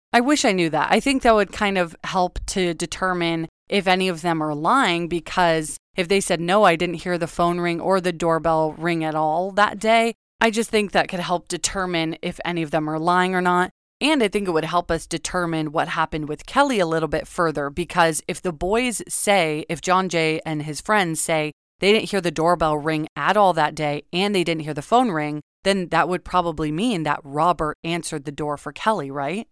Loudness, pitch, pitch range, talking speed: -21 LUFS, 175 Hz, 160-190 Hz, 230 wpm